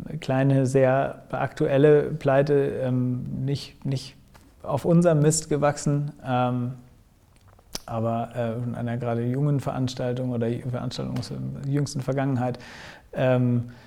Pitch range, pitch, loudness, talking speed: 120-140 Hz, 130 Hz, -25 LUFS, 95 wpm